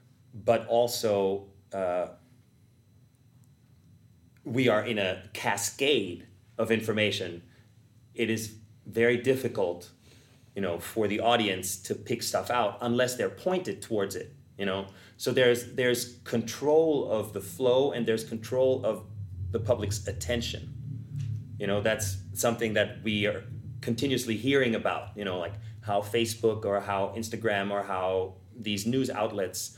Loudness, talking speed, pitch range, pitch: -29 LUFS, 135 wpm, 100-120 Hz, 115 Hz